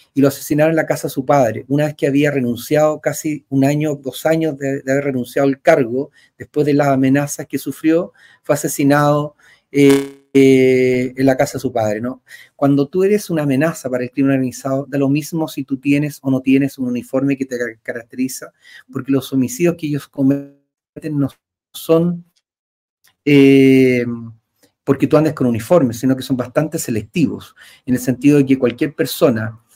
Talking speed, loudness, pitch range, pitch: 185 wpm, -16 LUFS, 130-150 Hz, 140 Hz